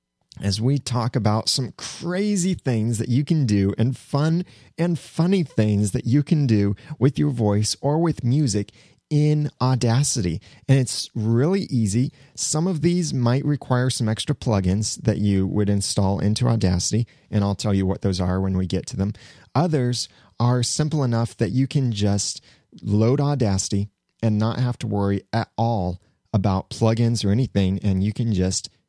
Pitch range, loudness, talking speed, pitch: 100-140 Hz, -22 LUFS, 170 wpm, 115 Hz